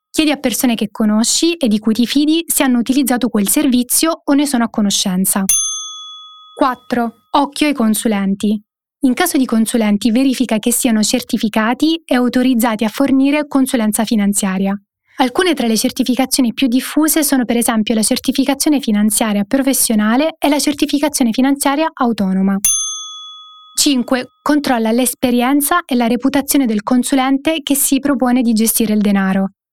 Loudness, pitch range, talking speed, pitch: -14 LUFS, 225-290 Hz, 145 wpm, 255 Hz